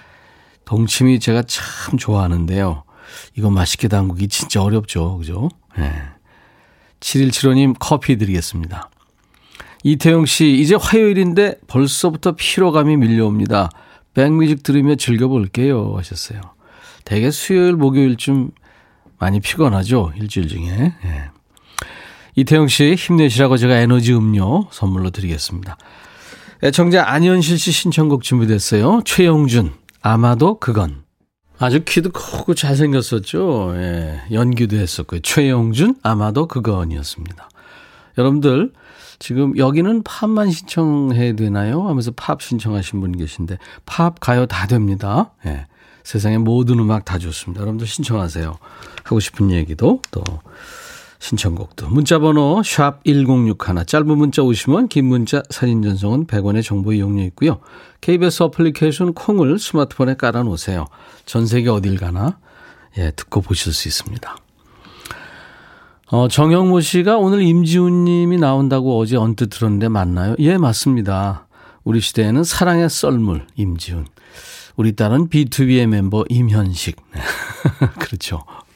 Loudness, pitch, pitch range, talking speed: -16 LUFS, 120 Hz, 100-150 Hz, 290 characters per minute